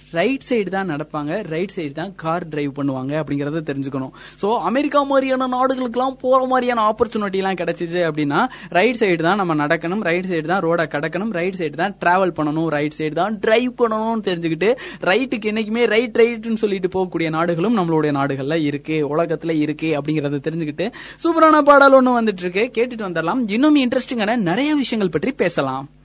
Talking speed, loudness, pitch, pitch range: 165 wpm, -19 LUFS, 185 Hz, 160-235 Hz